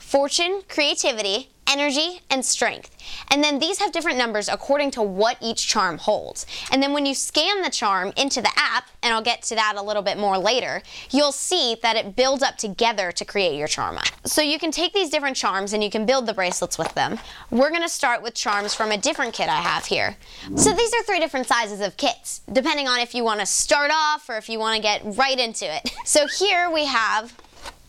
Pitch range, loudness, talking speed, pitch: 215-300 Hz, -21 LUFS, 225 wpm, 255 Hz